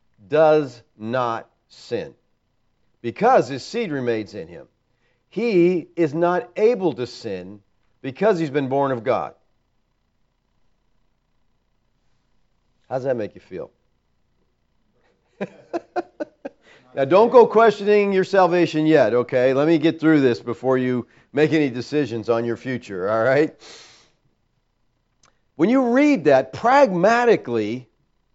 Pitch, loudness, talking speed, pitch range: 140 Hz, -19 LUFS, 115 wpm, 120-175 Hz